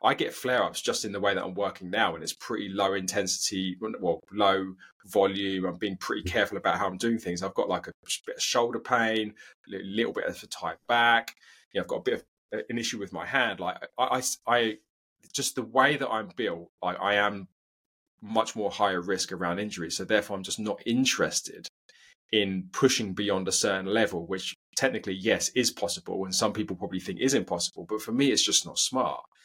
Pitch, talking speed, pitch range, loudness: 100 Hz, 215 wpm, 95-115 Hz, -28 LUFS